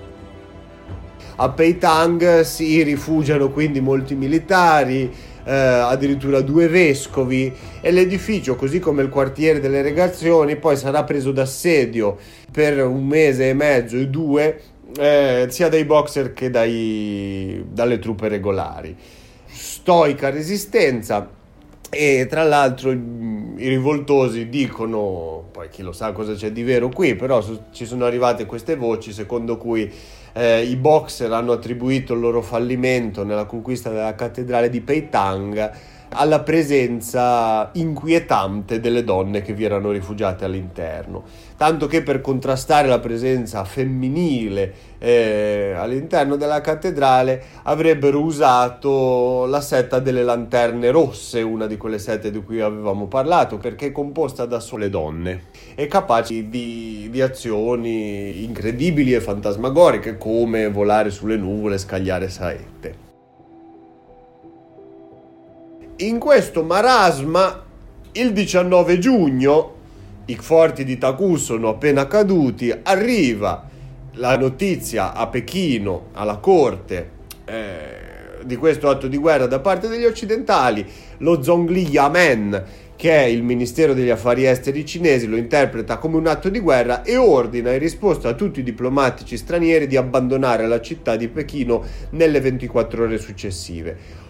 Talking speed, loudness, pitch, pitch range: 130 wpm, -18 LUFS, 125 Hz, 110-150 Hz